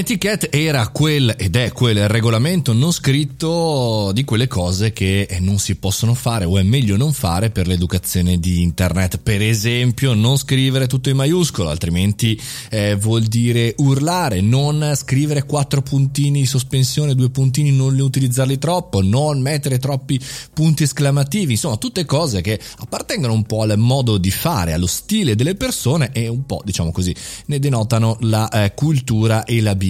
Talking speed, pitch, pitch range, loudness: 165 wpm, 120 Hz, 105-140 Hz, -17 LUFS